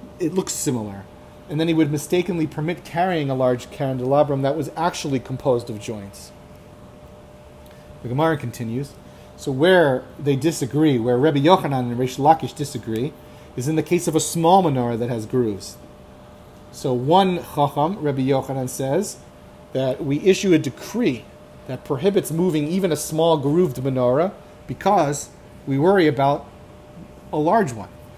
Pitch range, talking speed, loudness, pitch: 125-160 Hz, 150 wpm, -21 LUFS, 140 Hz